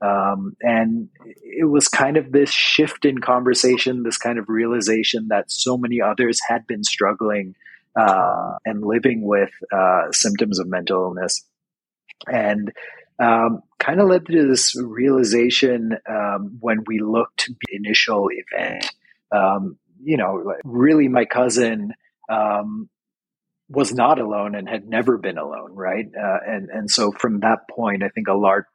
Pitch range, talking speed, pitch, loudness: 110-135 Hz, 150 wpm, 120 Hz, -19 LUFS